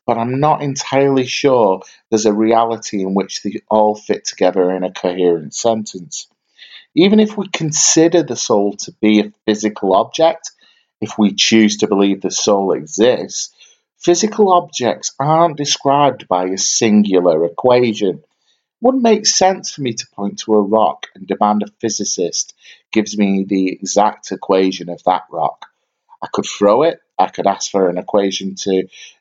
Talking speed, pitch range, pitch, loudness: 165 wpm, 100-150 Hz, 110 Hz, -15 LUFS